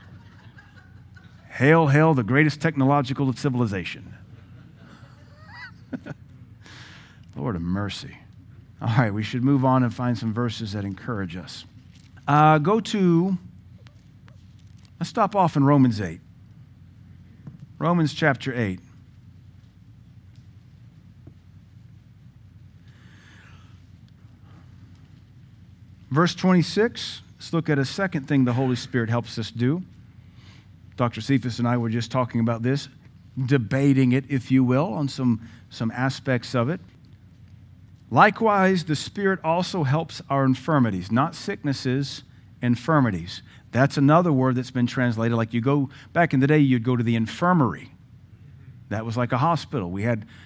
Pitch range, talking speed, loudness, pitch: 110-140 Hz, 120 wpm, -23 LUFS, 120 Hz